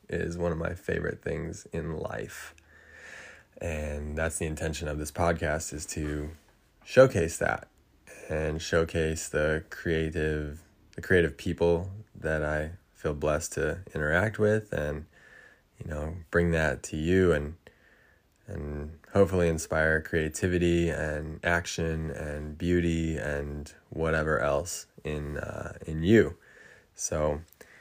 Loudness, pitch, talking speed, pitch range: -29 LUFS, 80 Hz, 125 wpm, 75-85 Hz